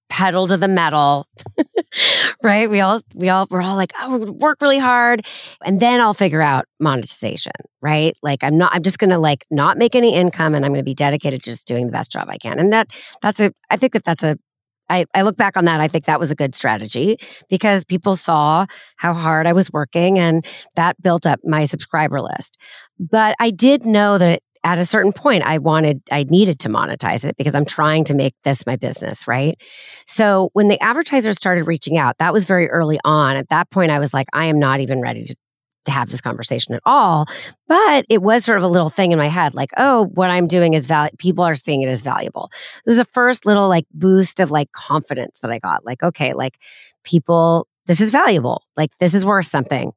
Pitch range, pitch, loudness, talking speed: 150-200 Hz, 175 Hz, -16 LUFS, 230 wpm